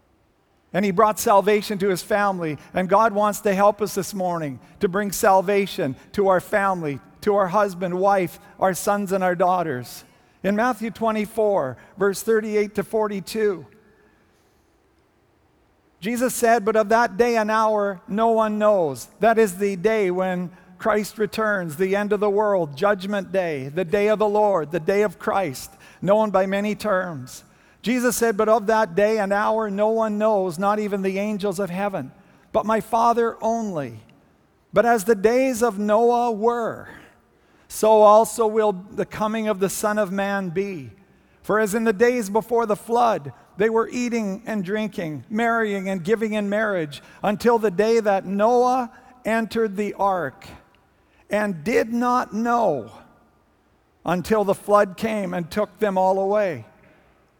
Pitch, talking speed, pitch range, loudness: 205 Hz, 160 wpm, 190-220 Hz, -21 LUFS